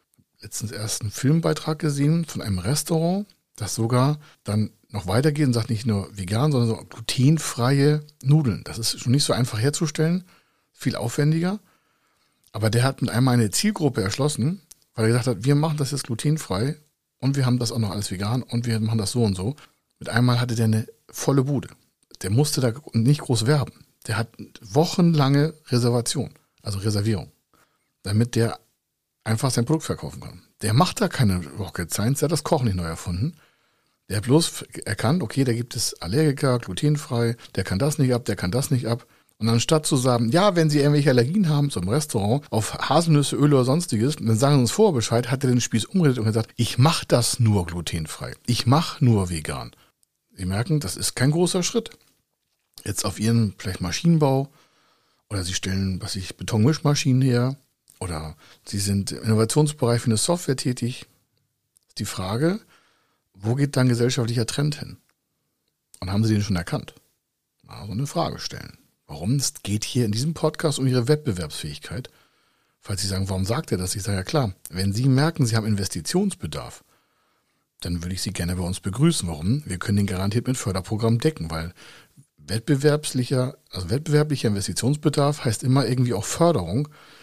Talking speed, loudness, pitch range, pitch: 180 wpm, -23 LUFS, 110-145 Hz, 120 Hz